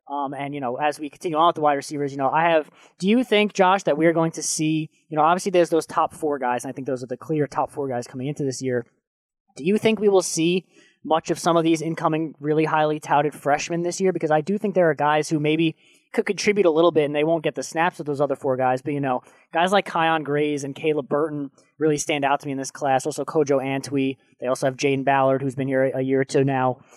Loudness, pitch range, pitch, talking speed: -22 LUFS, 135-165 Hz, 150 Hz, 275 wpm